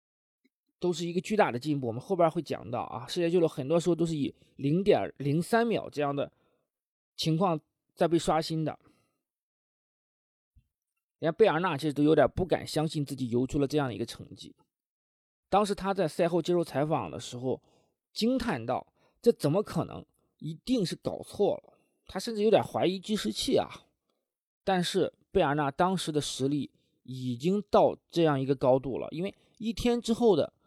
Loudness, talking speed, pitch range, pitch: -29 LUFS, 260 characters per minute, 140-190 Hz, 160 Hz